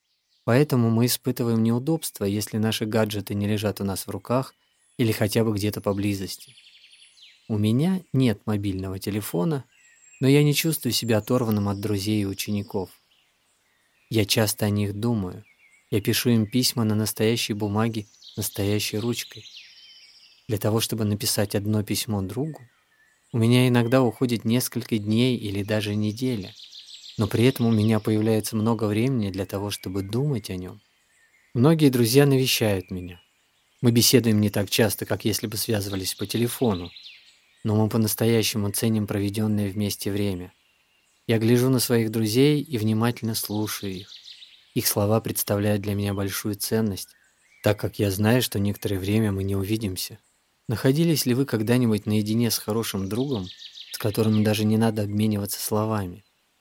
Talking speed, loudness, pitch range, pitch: 150 wpm, -24 LUFS, 105-120 Hz, 110 Hz